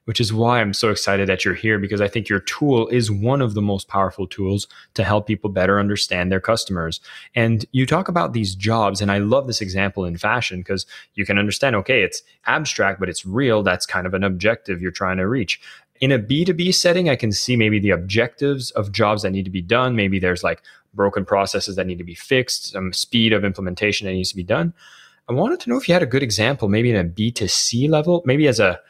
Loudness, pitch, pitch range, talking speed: -19 LUFS, 105 Hz, 95-125 Hz, 235 wpm